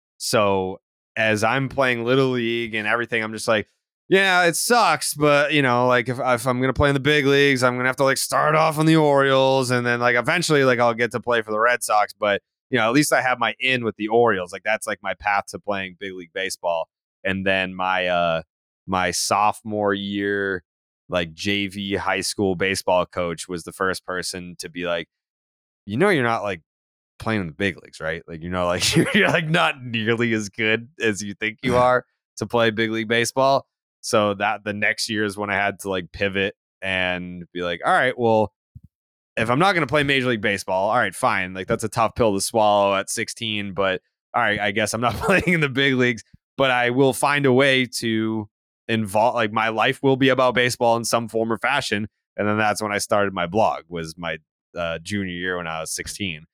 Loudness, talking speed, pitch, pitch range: -21 LUFS, 225 wpm, 110 Hz, 95-125 Hz